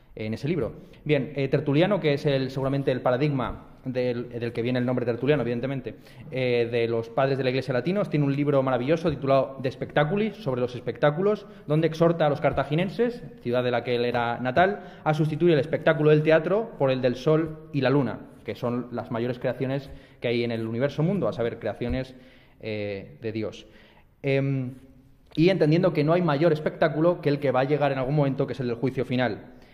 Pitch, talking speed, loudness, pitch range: 135 Hz, 210 wpm, -25 LUFS, 125-155 Hz